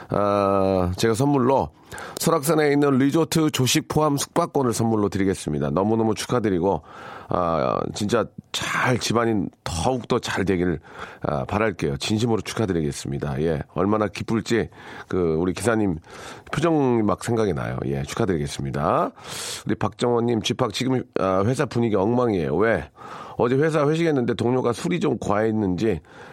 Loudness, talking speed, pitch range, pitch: -23 LUFS, 325 characters per minute, 95-130 Hz, 115 Hz